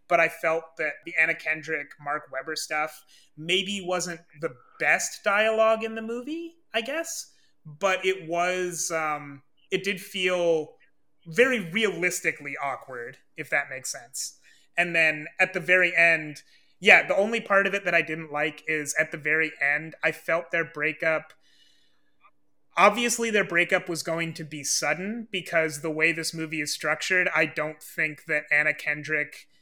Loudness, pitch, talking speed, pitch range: -25 LUFS, 165 Hz, 160 wpm, 155-185 Hz